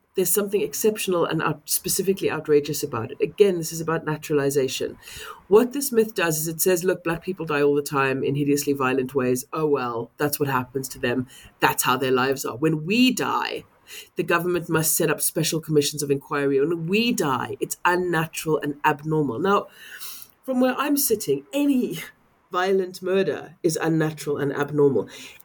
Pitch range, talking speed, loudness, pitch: 145-190 Hz, 175 wpm, -23 LUFS, 160 Hz